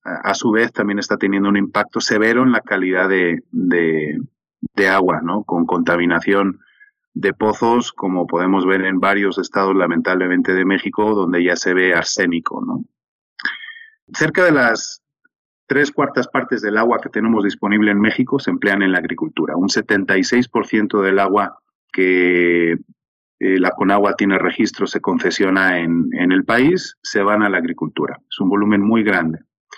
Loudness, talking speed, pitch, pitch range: -17 LUFS, 160 wpm, 100 Hz, 90-110 Hz